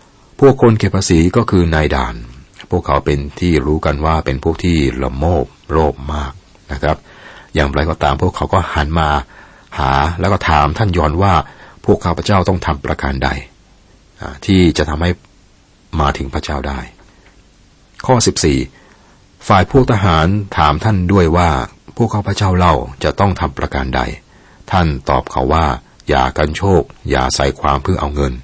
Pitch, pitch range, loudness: 80 Hz, 70-90 Hz, -15 LUFS